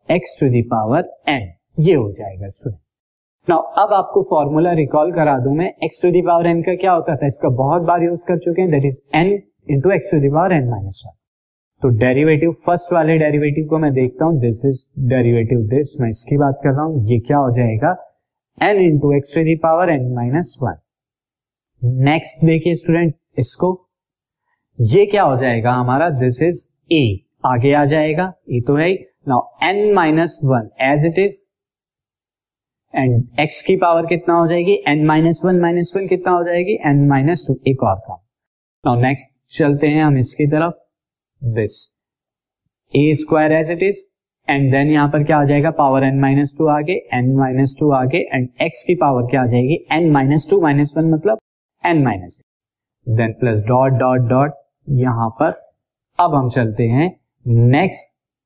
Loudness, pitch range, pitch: -16 LUFS, 130-165 Hz, 145 Hz